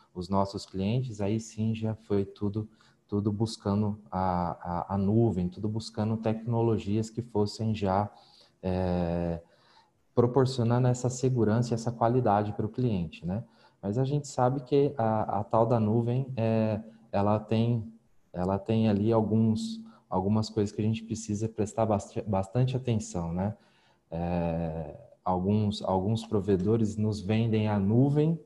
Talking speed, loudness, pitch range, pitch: 140 wpm, -29 LUFS, 100-115 Hz, 110 Hz